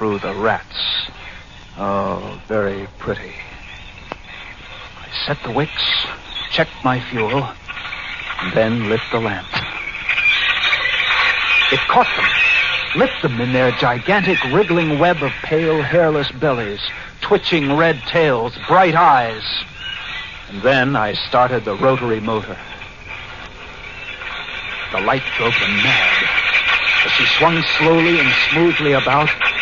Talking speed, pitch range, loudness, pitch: 115 wpm, 110-170 Hz, -16 LUFS, 140 Hz